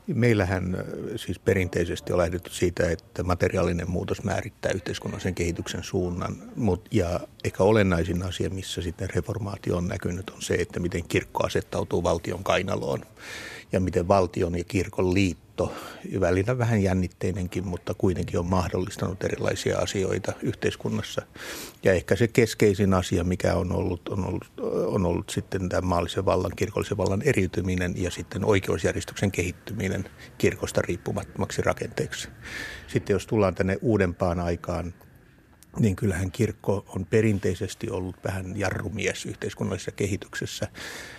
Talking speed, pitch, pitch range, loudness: 130 wpm, 95 Hz, 90-105 Hz, -27 LUFS